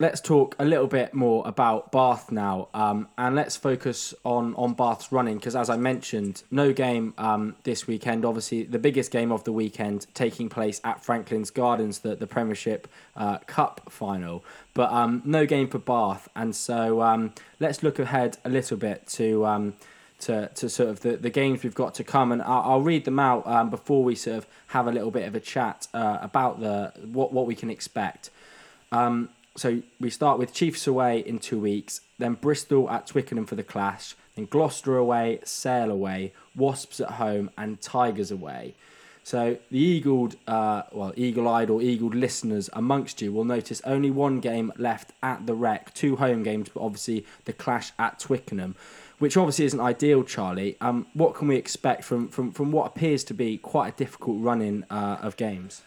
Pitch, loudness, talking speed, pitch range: 120 Hz, -26 LUFS, 195 wpm, 110-135 Hz